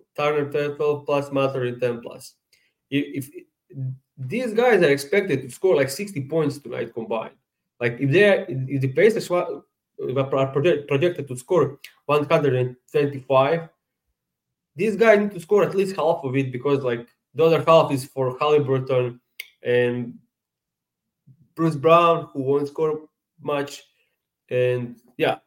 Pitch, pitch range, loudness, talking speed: 145 Hz, 130-165 Hz, -22 LUFS, 150 wpm